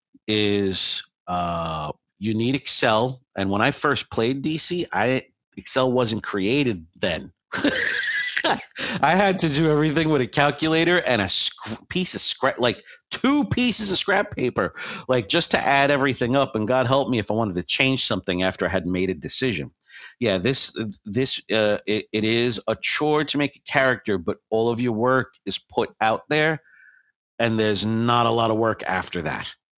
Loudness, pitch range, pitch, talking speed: -22 LUFS, 105-145 Hz, 120 Hz, 175 wpm